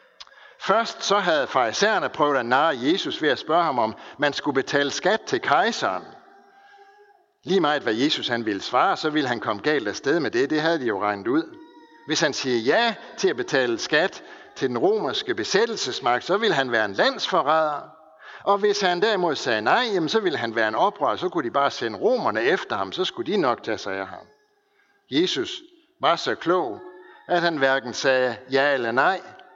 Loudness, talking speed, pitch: -23 LUFS, 200 wpm, 230 Hz